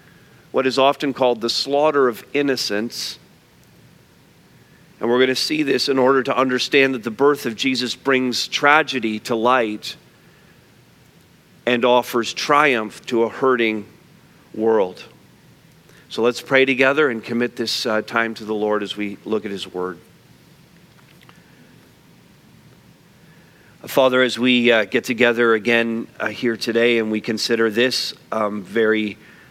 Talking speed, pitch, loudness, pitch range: 140 wpm, 120 Hz, -19 LUFS, 110-130 Hz